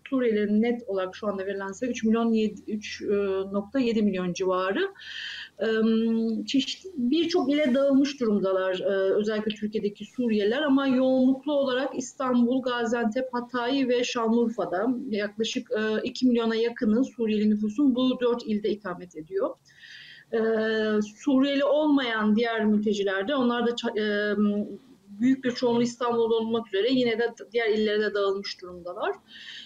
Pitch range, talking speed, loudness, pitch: 210-255 Hz, 115 wpm, -26 LUFS, 230 Hz